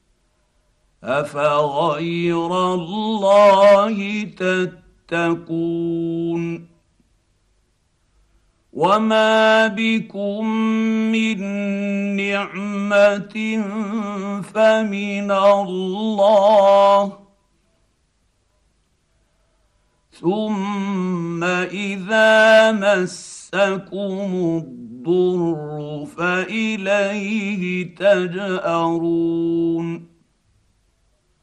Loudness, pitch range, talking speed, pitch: -18 LUFS, 170-205 Hz, 30 wpm, 200 Hz